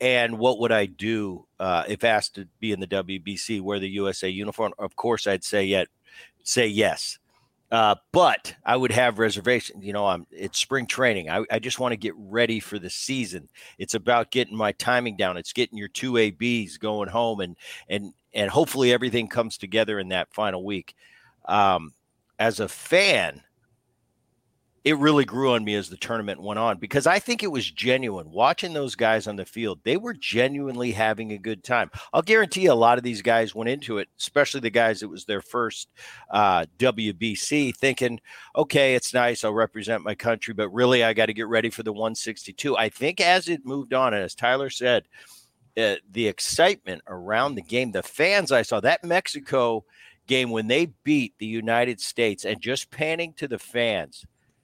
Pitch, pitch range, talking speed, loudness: 115 Hz, 105-125 Hz, 195 wpm, -24 LUFS